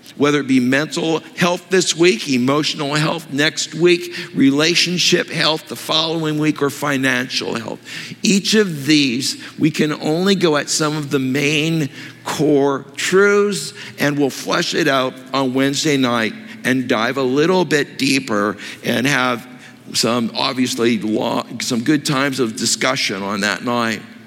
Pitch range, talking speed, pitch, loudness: 130-165 Hz, 150 wpm, 145 Hz, -17 LUFS